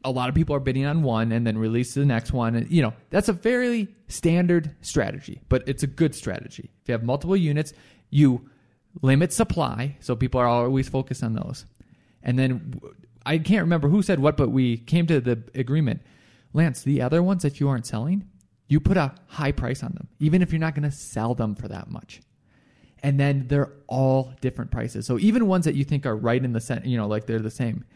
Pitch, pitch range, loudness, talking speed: 135 Hz, 120-155 Hz, -24 LUFS, 230 wpm